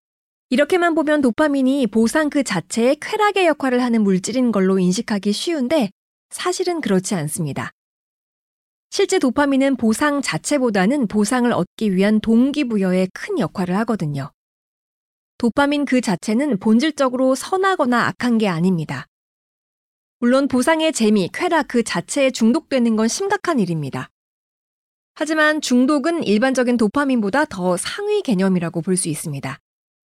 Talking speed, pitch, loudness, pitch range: 310 characters per minute, 245 Hz, -18 LUFS, 195-290 Hz